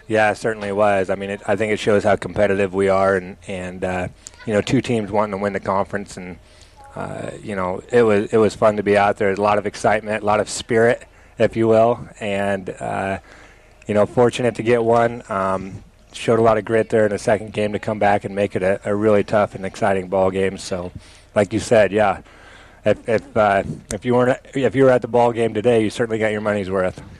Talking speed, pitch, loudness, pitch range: 245 wpm, 105 Hz, -19 LUFS, 95-110 Hz